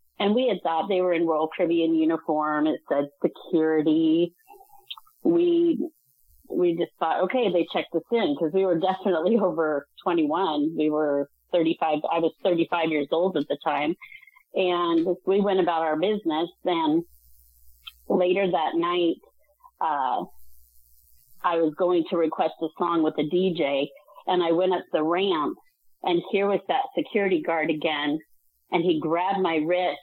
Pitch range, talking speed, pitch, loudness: 155-200 Hz, 155 wpm, 175 Hz, -25 LUFS